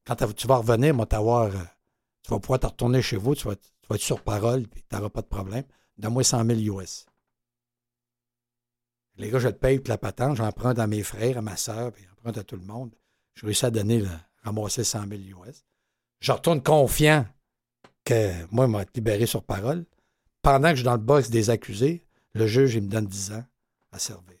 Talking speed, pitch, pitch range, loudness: 210 wpm, 115 Hz, 105-130 Hz, -25 LUFS